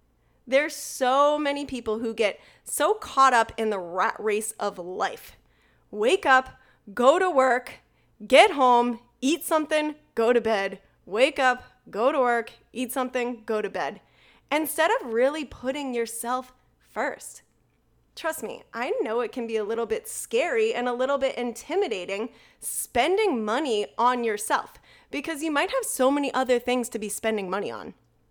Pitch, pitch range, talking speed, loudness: 255 Hz, 230-290 Hz, 160 wpm, -25 LUFS